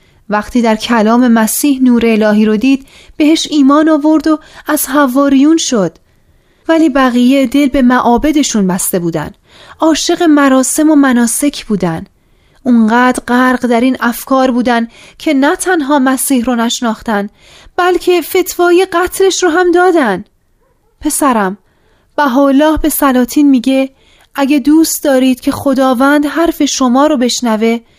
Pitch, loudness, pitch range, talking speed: 270 Hz, -10 LUFS, 240-305 Hz, 130 wpm